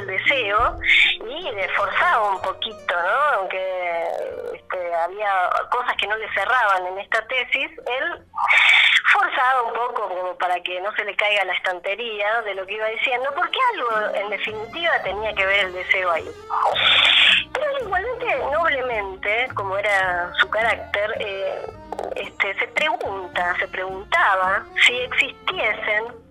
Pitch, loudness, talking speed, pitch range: 215 Hz, -20 LUFS, 145 wpm, 190-295 Hz